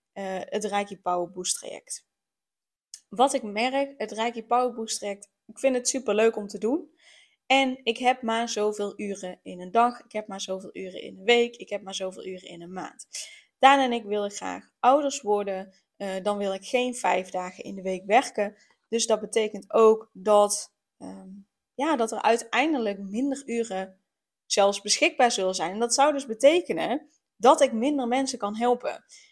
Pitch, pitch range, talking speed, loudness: 220 Hz, 200-250 Hz, 185 wpm, -25 LUFS